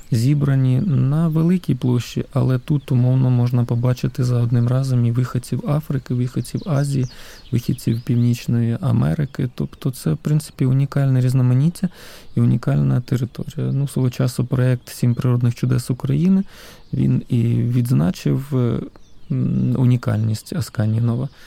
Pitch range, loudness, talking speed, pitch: 120-140 Hz, -20 LUFS, 120 wpm, 125 Hz